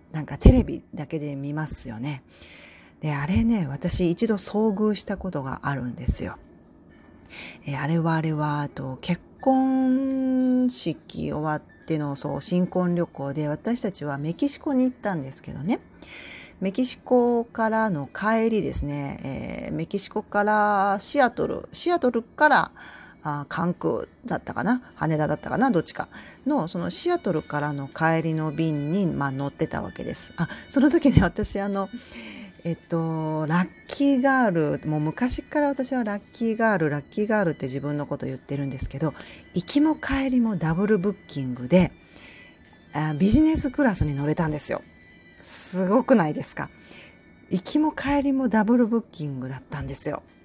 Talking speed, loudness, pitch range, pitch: 320 characters per minute, -25 LUFS, 150-235 Hz, 175 Hz